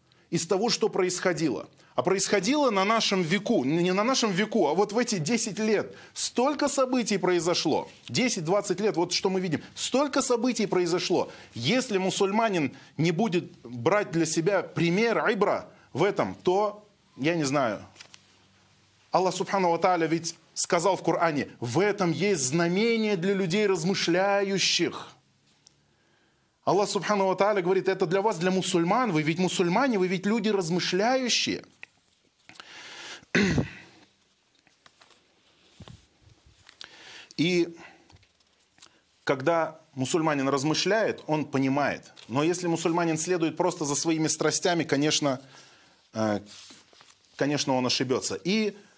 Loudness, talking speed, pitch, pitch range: -26 LUFS, 115 wpm, 180 Hz, 160-205 Hz